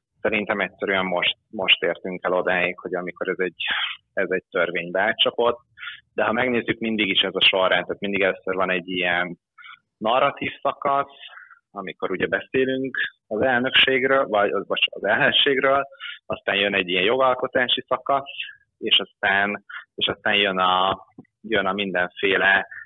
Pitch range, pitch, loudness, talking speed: 95-135 Hz, 105 Hz, -21 LUFS, 145 wpm